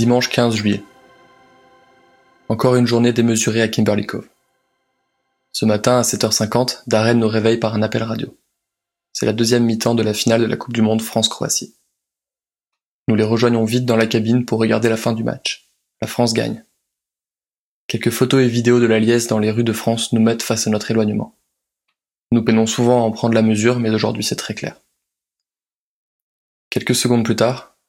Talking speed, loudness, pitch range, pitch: 185 wpm, -17 LUFS, 110-120 Hz, 115 Hz